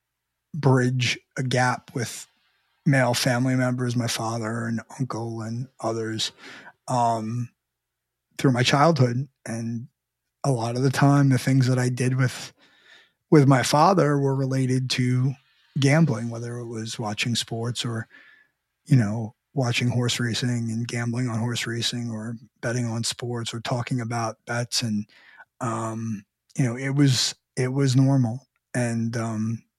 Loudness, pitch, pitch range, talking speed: -24 LUFS, 120 Hz, 115-130 Hz, 145 wpm